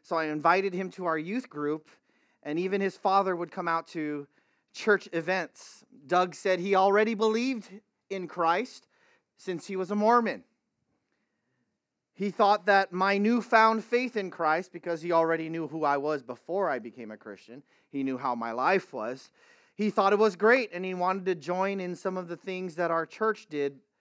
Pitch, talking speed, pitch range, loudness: 185 Hz, 185 wpm, 165-205 Hz, -28 LUFS